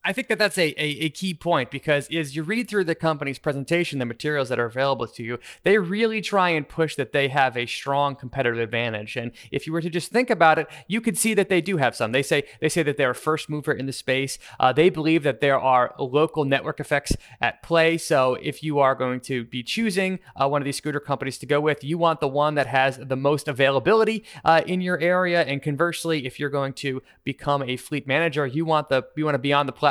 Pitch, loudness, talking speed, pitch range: 150 Hz, -23 LUFS, 255 wpm, 135-165 Hz